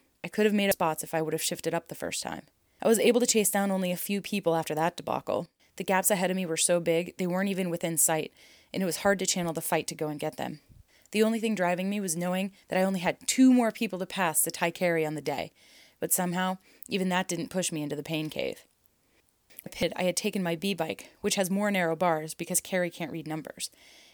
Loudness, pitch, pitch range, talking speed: -28 LUFS, 180 Hz, 165-195 Hz, 255 wpm